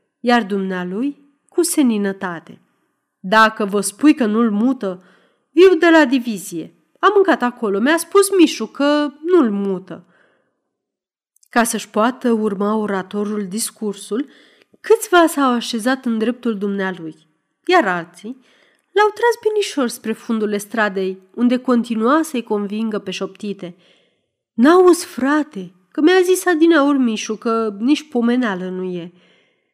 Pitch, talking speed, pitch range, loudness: 230 Hz, 125 wpm, 200-295 Hz, -17 LUFS